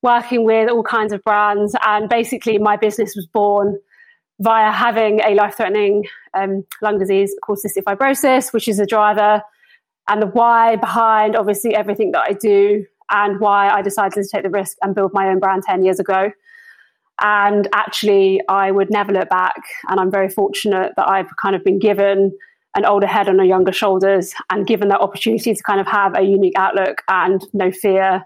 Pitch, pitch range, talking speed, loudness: 205 Hz, 195-220 Hz, 190 wpm, -16 LUFS